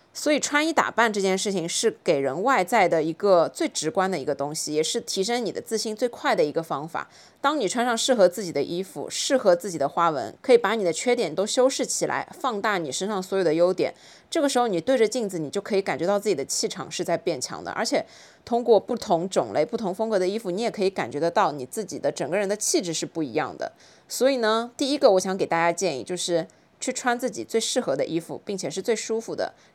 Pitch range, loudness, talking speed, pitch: 175-235 Hz, -24 LUFS, 355 characters per minute, 200 Hz